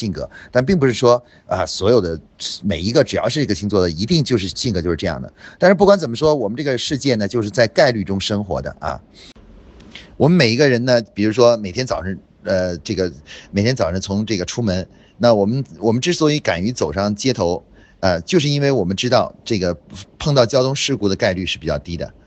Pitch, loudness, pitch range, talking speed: 110 Hz, -18 LUFS, 95-130 Hz, 330 characters per minute